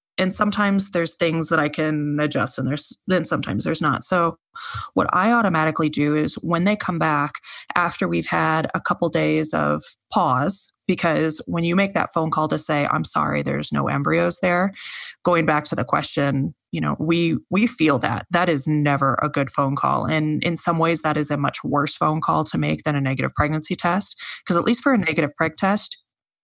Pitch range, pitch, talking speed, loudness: 145-180 Hz, 160 Hz, 205 wpm, -21 LUFS